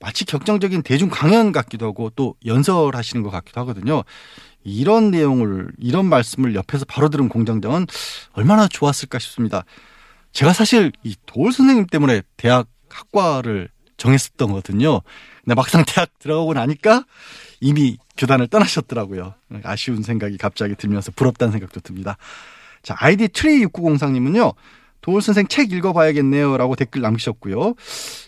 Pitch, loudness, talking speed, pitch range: 135 Hz, -18 LUFS, 350 characters per minute, 115-170 Hz